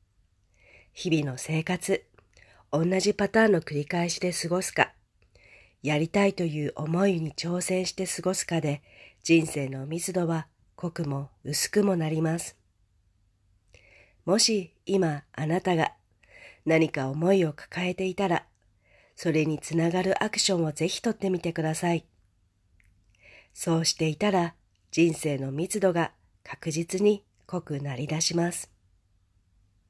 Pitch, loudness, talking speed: 160 Hz, -27 LUFS, 245 characters per minute